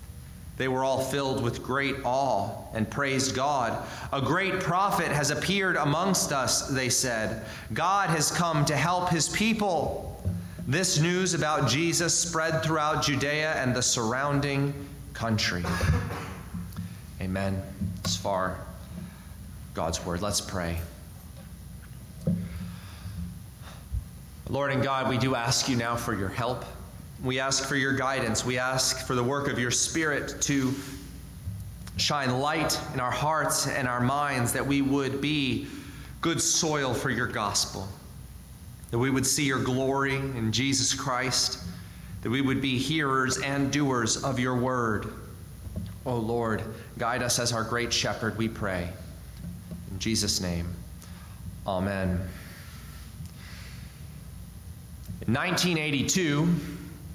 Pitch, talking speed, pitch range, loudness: 125 Hz, 125 wpm, 95-140 Hz, -27 LUFS